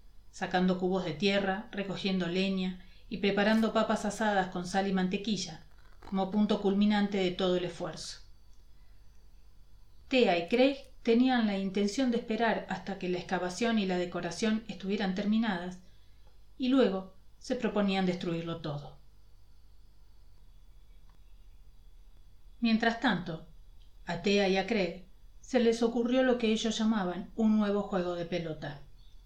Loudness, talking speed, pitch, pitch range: -30 LUFS, 130 wpm, 190 Hz, 145-215 Hz